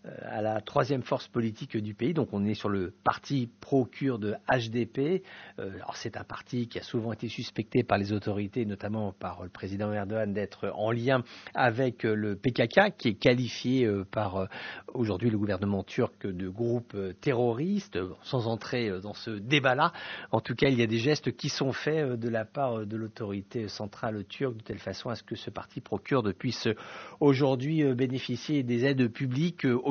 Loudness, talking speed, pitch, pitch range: -30 LUFS, 185 wpm, 120 Hz, 105-130 Hz